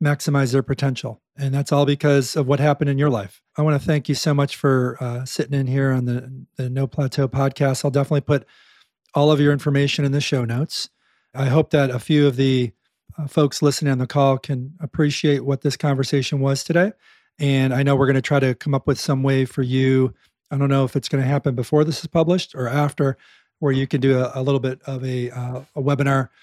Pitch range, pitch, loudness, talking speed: 130-145 Hz, 140 Hz, -20 LUFS, 235 wpm